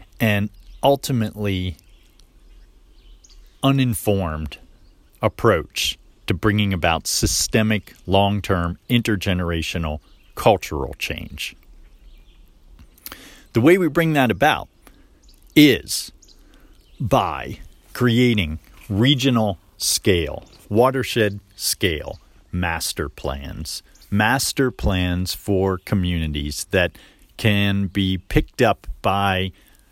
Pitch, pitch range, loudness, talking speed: 95 Hz, 85-110 Hz, -20 LUFS, 75 wpm